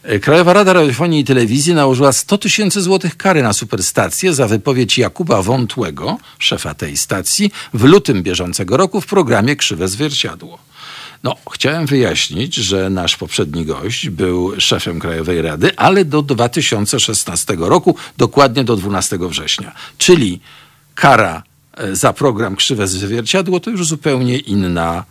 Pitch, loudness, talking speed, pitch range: 125 Hz, -14 LUFS, 135 wpm, 95-155 Hz